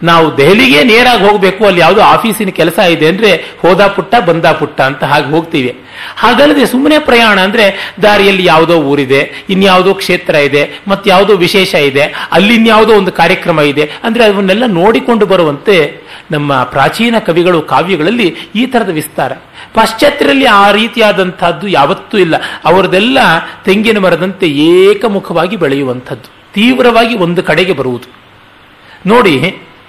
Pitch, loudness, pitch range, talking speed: 190 Hz, -8 LUFS, 165-220 Hz, 125 wpm